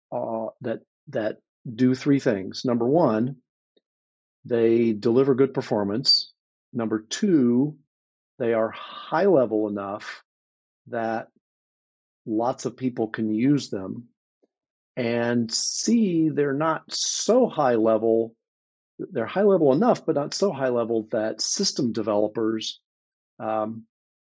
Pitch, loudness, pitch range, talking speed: 115 Hz, -24 LUFS, 110-135 Hz, 115 wpm